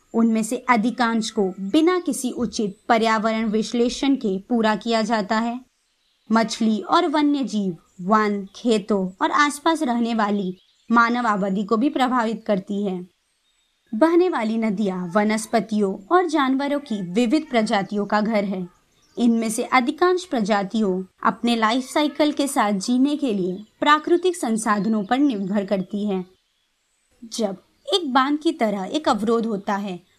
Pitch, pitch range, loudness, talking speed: 225 Hz, 205-260 Hz, -21 LUFS, 140 wpm